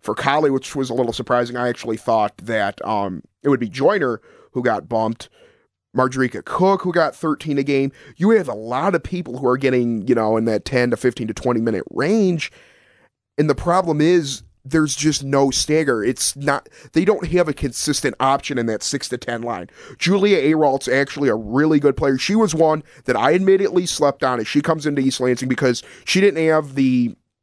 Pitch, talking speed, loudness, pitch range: 135 Hz, 205 wpm, -19 LUFS, 125-160 Hz